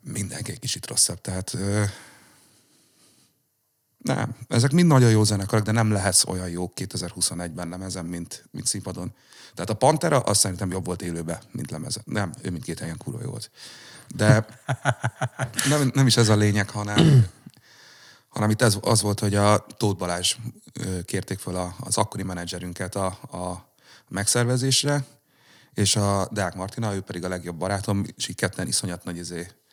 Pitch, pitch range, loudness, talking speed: 100 Hz, 90-120 Hz, -24 LUFS, 160 wpm